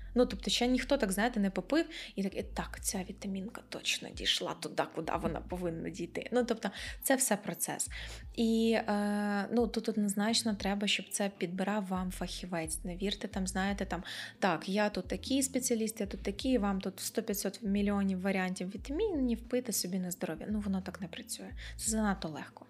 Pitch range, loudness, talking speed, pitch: 190-230 Hz, -34 LUFS, 180 wpm, 205 Hz